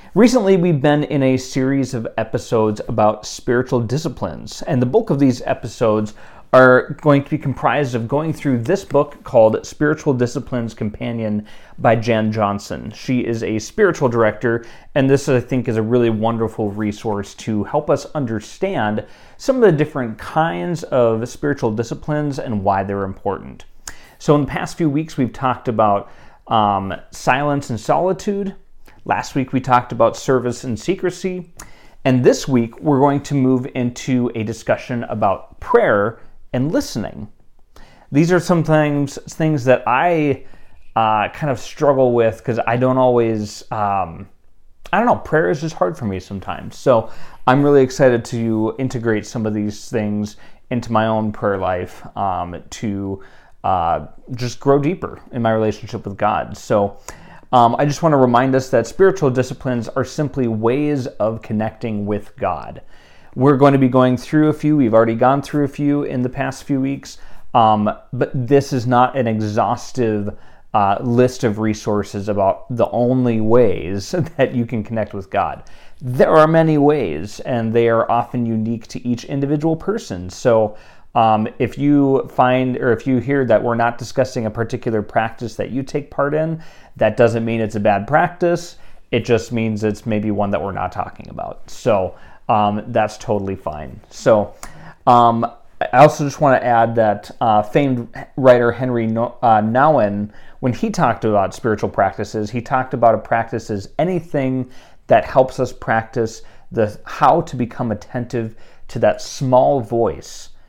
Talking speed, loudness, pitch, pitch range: 165 wpm, -18 LUFS, 120 Hz, 110-140 Hz